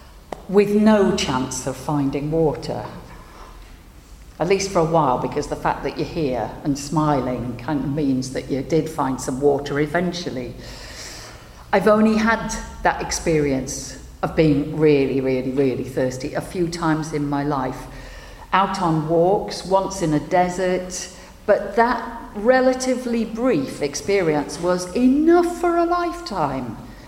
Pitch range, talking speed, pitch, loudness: 135-195 Hz, 140 wpm, 155 Hz, -21 LUFS